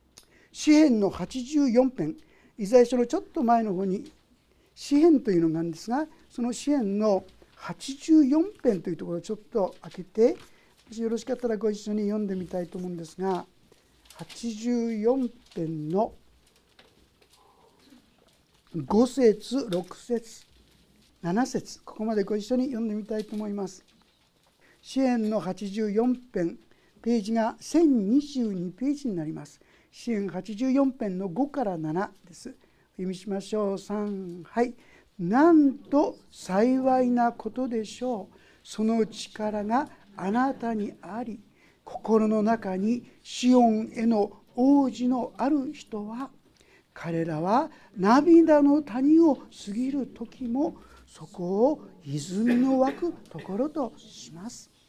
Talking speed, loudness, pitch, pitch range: 220 characters per minute, -26 LUFS, 225 Hz, 200-255 Hz